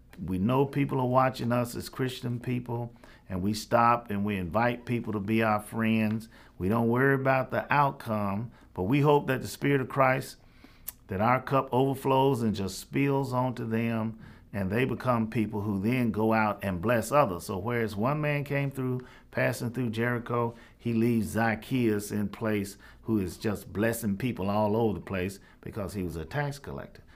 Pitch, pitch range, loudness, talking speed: 115 Hz, 105-125 Hz, -29 LUFS, 185 wpm